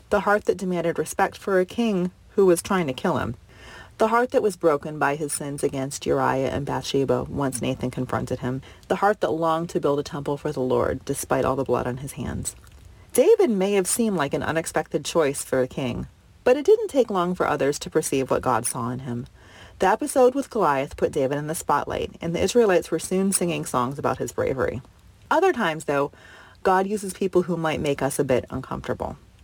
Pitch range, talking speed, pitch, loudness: 135-195 Hz, 215 wpm, 160 Hz, -24 LUFS